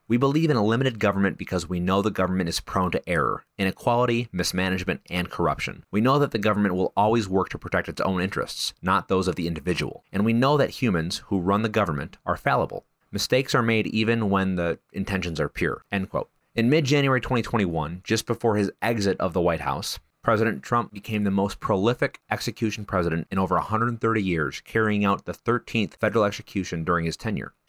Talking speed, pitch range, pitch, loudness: 200 wpm, 90-115 Hz, 100 Hz, -25 LUFS